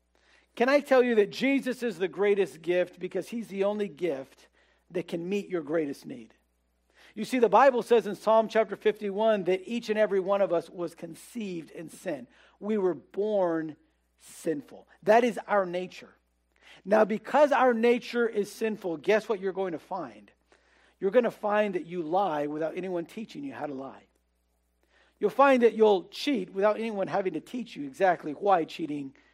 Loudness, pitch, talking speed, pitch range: -27 LUFS, 200 Hz, 180 wpm, 175-225 Hz